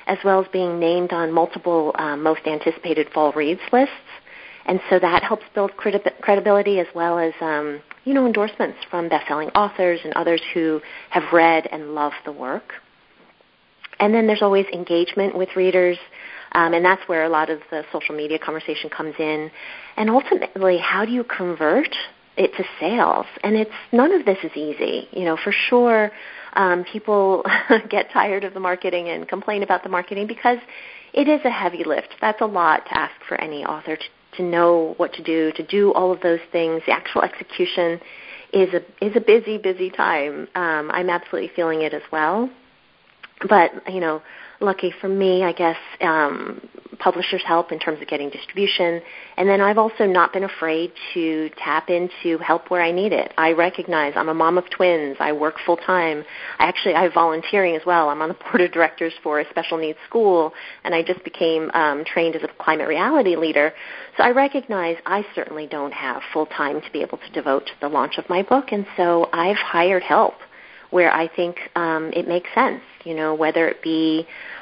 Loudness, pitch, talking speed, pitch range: -20 LUFS, 175 Hz, 195 wpm, 160-195 Hz